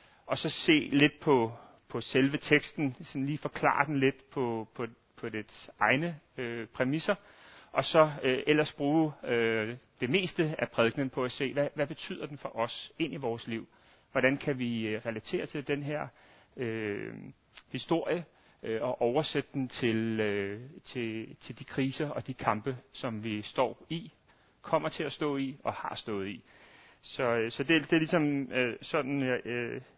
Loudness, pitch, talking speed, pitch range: -31 LUFS, 135 Hz, 180 wpm, 115-150 Hz